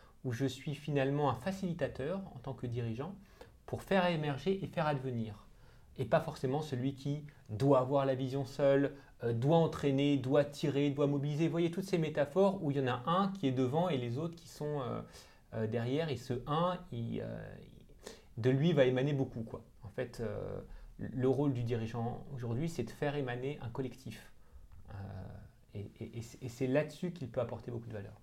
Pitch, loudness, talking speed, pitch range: 135 Hz, -35 LUFS, 200 wpm, 120-150 Hz